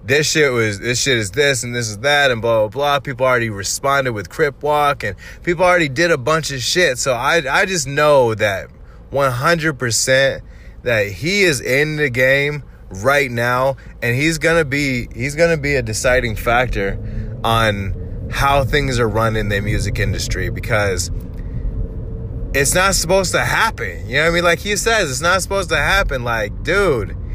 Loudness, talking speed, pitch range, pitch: -16 LUFS, 190 wpm, 110-150 Hz, 130 Hz